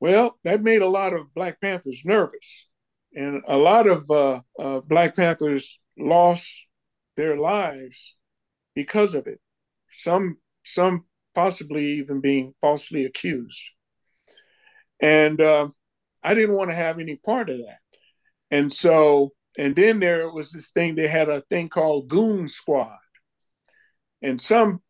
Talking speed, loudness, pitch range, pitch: 140 wpm, -21 LUFS, 145-200 Hz, 170 Hz